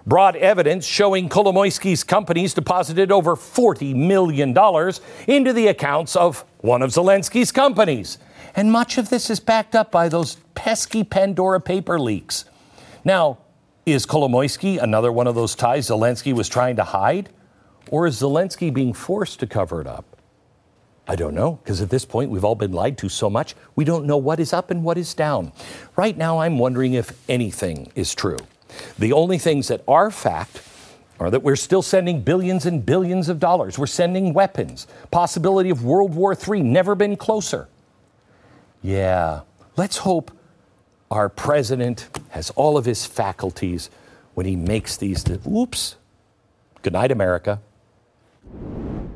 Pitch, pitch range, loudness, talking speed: 160 Hz, 120-185 Hz, -20 LUFS, 155 wpm